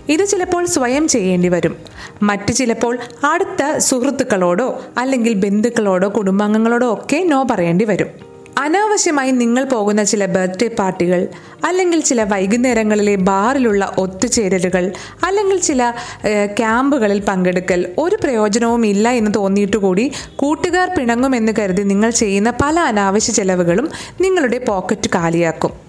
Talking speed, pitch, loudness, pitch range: 110 wpm, 230 Hz, -15 LUFS, 200-265 Hz